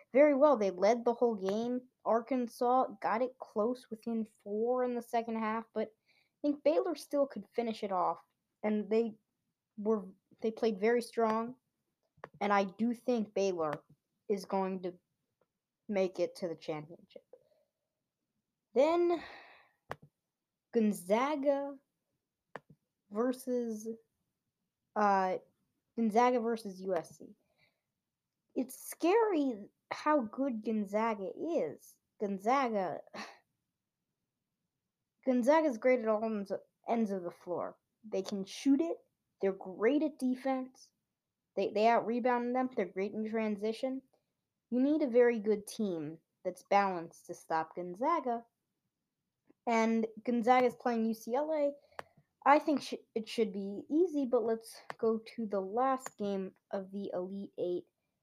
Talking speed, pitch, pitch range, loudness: 120 wpm, 230 Hz, 205-260 Hz, -34 LUFS